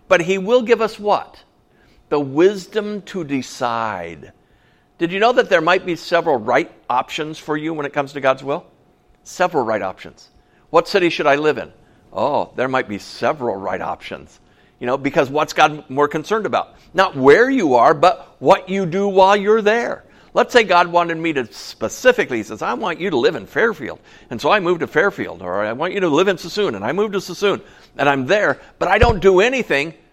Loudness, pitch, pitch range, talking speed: -18 LUFS, 175 Hz, 145-200 Hz, 210 wpm